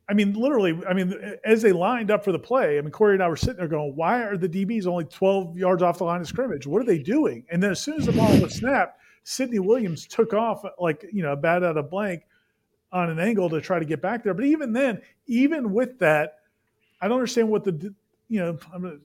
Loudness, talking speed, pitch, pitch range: -24 LUFS, 260 wpm, 190 Hz, 170-225 Hz